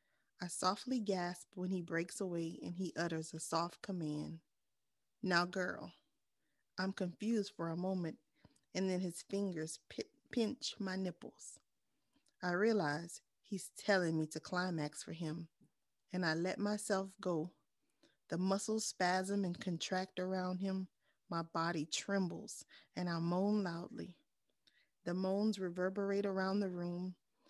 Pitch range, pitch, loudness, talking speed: 170-195 Hz, 185 Hz, -40 LUFS, 135 wpm